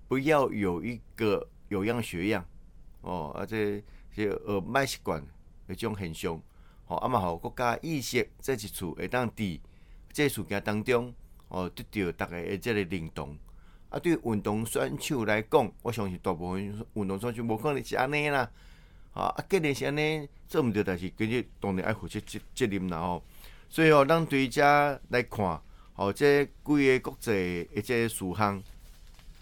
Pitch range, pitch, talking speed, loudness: 90-125 Hz, 105 Hz, 255 characters per minute, -30 LUFS